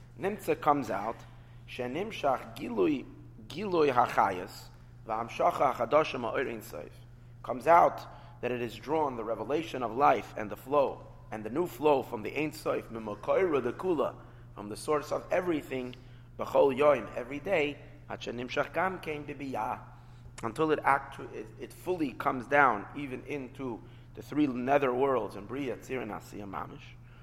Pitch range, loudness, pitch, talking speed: 120-145 Hz, -31 LUFS, 125 Hz, 130 wpm